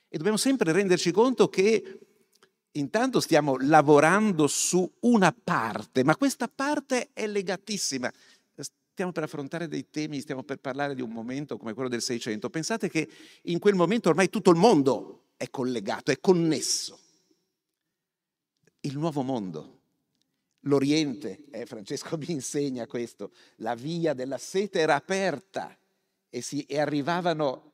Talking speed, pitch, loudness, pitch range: 140 wpm, 160 Hz, -26 LUFS, 140-200 Hz